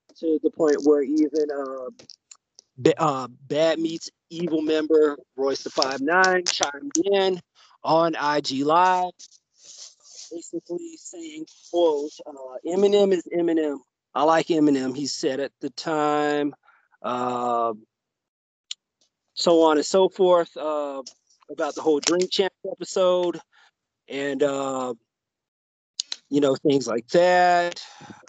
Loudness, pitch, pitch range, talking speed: -23 LUFS, 155 Hz, 140-180 Hz, 115 wpm